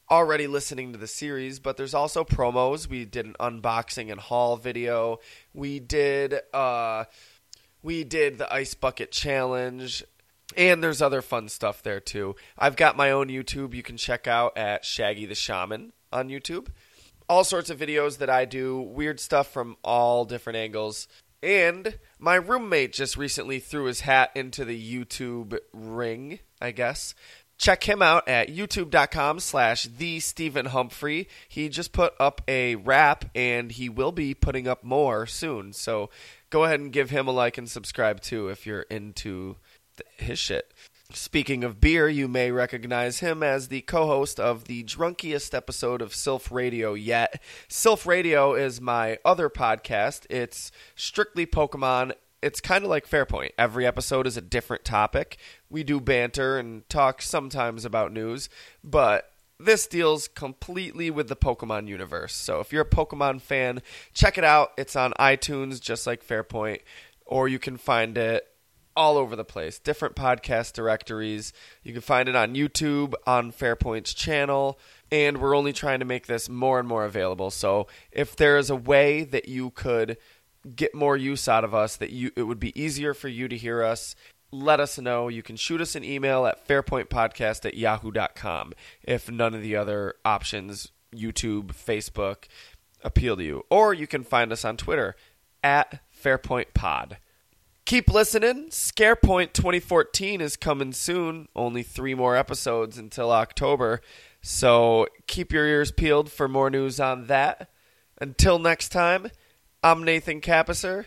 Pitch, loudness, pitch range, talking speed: 130 Hz, -25 LUFS, 115-145 Hz, 165 wpm